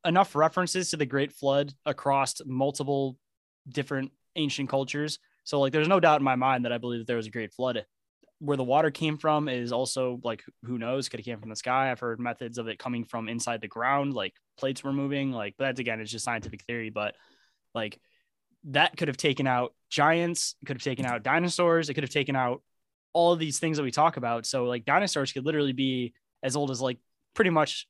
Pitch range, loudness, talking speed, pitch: 120-150 Hz, -28 LUFS, 220 wpm, 135 Hz